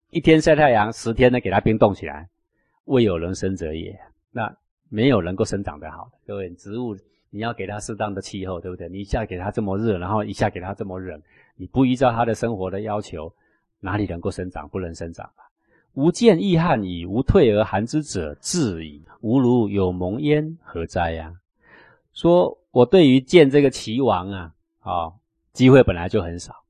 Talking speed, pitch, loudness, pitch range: 280 characters per minute, 105 Hz, -20 LUFS, 90-125 Hz